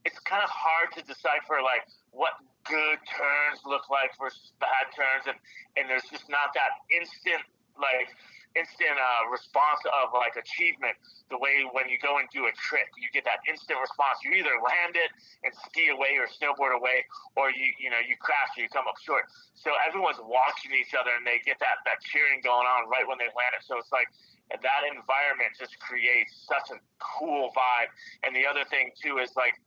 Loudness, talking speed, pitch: -27 LUFS, 200 wpm, 145 Hz